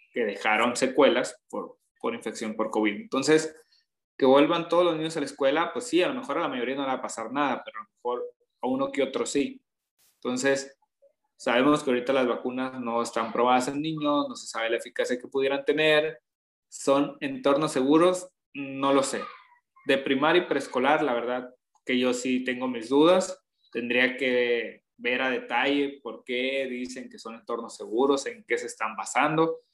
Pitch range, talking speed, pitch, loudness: 125-155 Hz, 190 wpm, 140 Hz, -26 LUFS